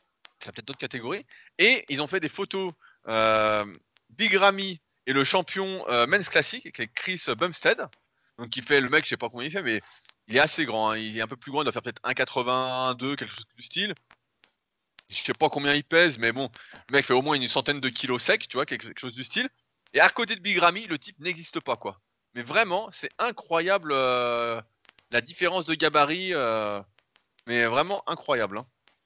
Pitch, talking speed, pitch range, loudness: 135 Hz, 215 wpm, 120-170 Hz, -25 LUFS